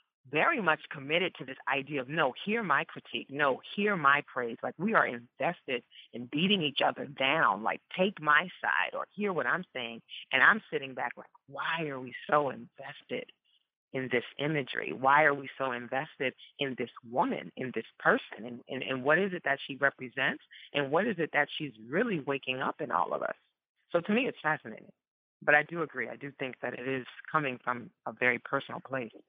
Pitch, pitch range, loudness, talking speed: 140 Hz, 130-155 Hz, -31 LUFS, 205 wpm